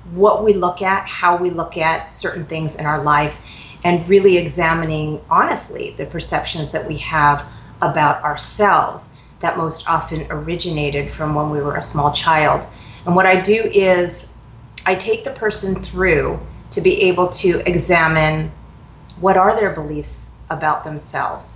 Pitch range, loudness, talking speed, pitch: 150-185 Hz, -17 LUFS, 155 wpm, 165 Hz